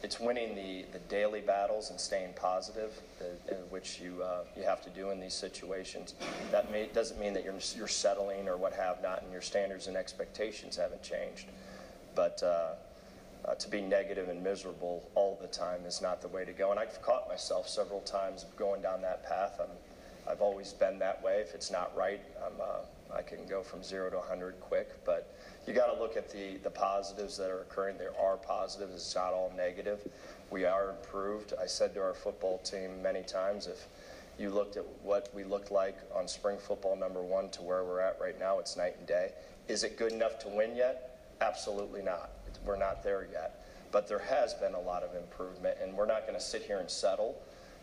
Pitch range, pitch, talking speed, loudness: 95-105 Hz, 95 Hz, 215 wpm, -36 LUFS